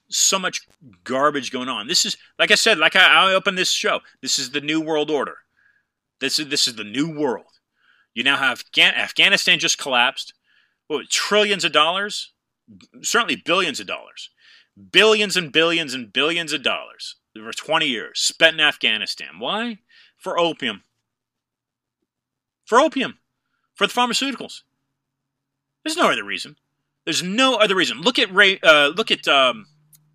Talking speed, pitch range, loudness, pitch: 155 wpm, 135-205 Hz, -18 LUFS, 160 Hz